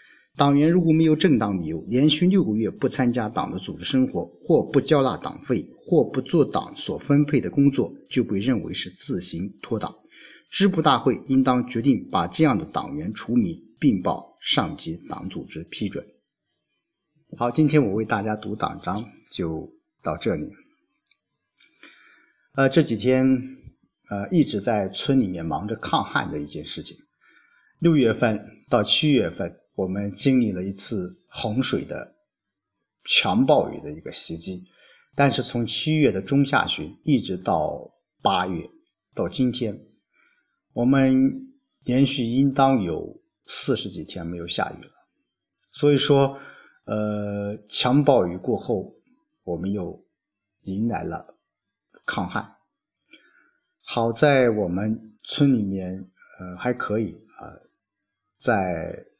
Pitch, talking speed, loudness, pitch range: 130 Hz, 200 characters per minute, -23 LUFS, 105-145 Hz